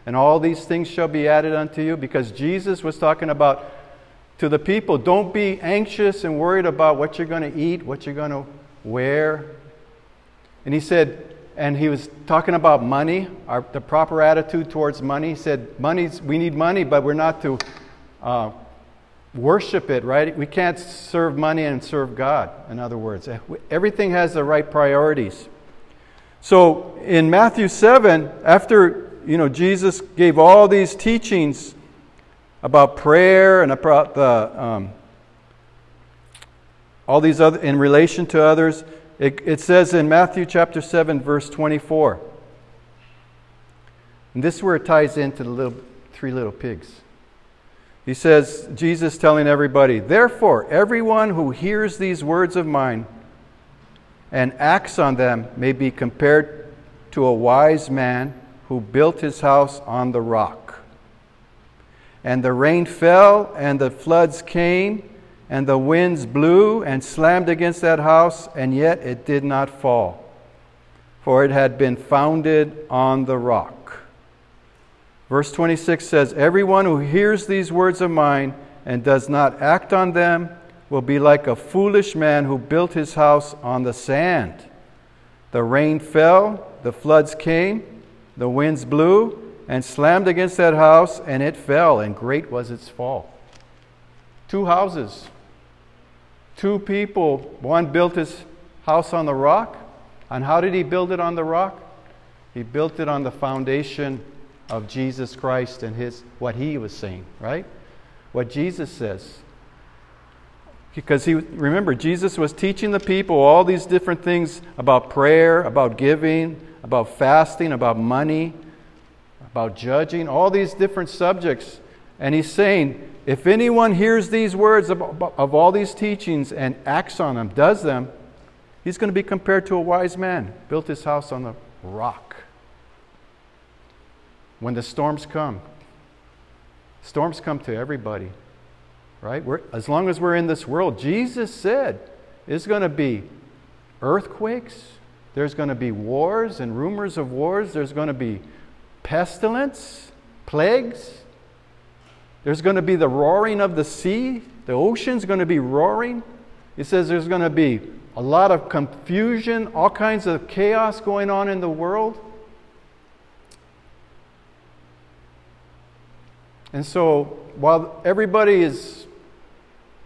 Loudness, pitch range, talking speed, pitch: -18 LUFS, 125-175 Hz, 145 wpm, 150 Hz